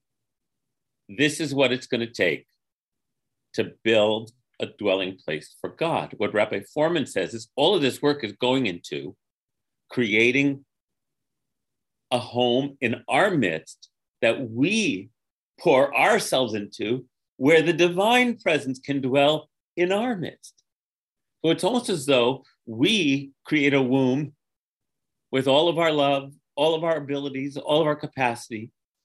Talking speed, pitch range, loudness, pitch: 140 wpm, 125-150 Hz, -23 LUFS, 135 Hz